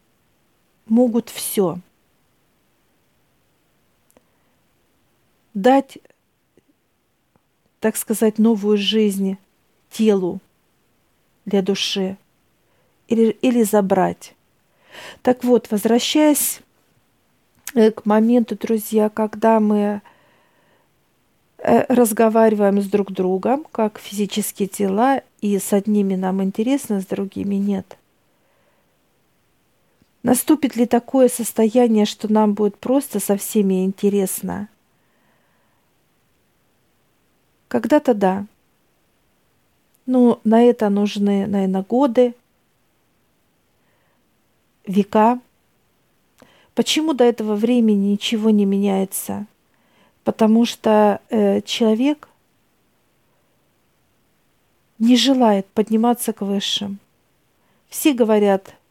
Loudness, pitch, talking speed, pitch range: -18 LUFS, 215 Hz, 75 wpm, 200-235 Hz